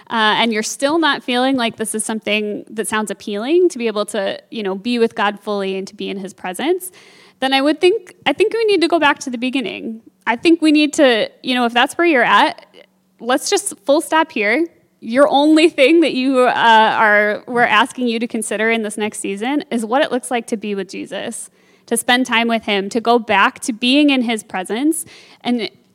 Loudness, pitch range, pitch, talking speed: -16 LUFS, 215-285 Hz, 240 Hz, 230 wpm